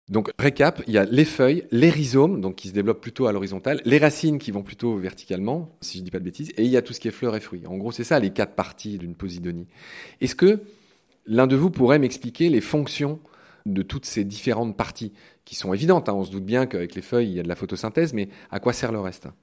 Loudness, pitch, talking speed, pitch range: -23 LUFS, 115 Hz, 265 wpm, 95-145 Hz